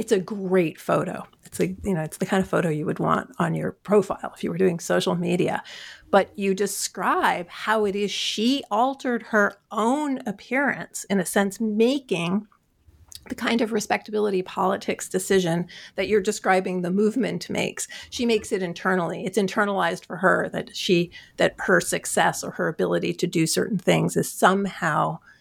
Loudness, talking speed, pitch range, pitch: -24 LUFS, 175 wpm, 180-215 Hz, 200 Hz